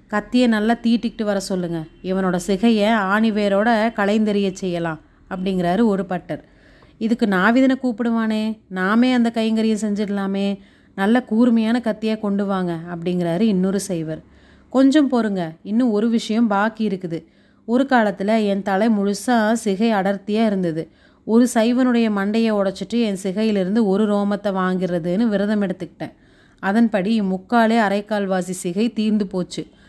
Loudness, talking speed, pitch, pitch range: -19 LUFS, 120 wpm, 210 Hz, 190-225 Hz